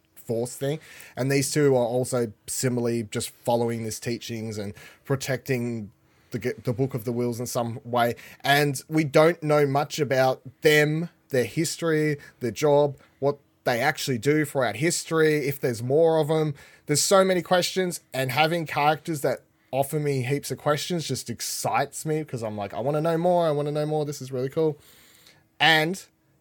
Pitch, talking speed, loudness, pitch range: 140 Hz, 180 wpm, -25 LUFS, 125-155 Hz